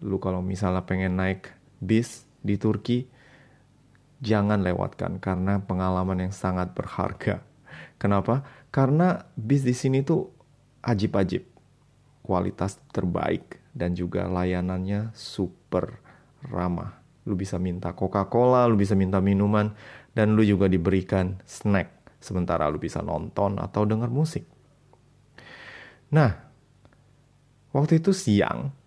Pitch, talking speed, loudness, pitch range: 105 Hz, 110 wpm, -26 LUFS, 95-130 Hz